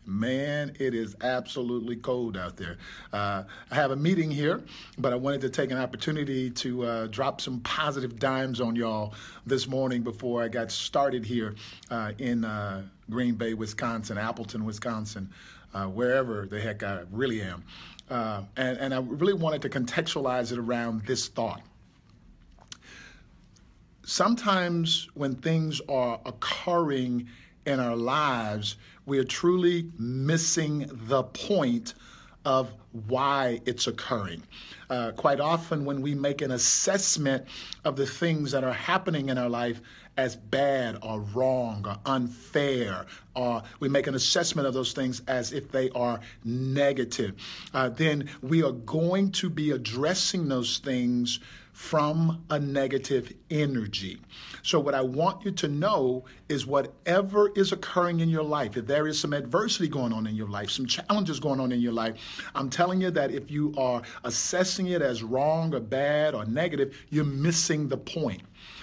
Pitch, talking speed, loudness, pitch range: 130 Hz, 155 wpm, -28 LUFS, 120-150 Hz